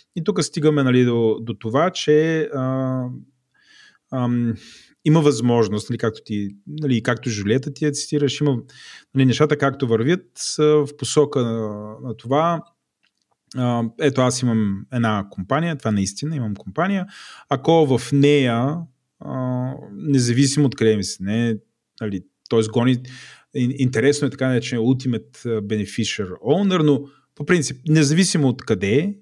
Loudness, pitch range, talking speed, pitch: -20 LUFS, 115-145 Hz, 145 wpm, 130 Hz